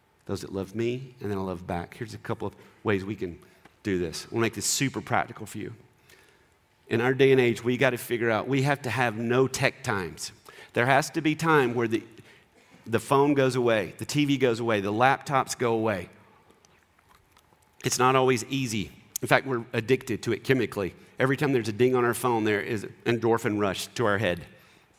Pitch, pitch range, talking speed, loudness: 120 Hz, 105-130 Hz, 210 wpm, -26 LUFS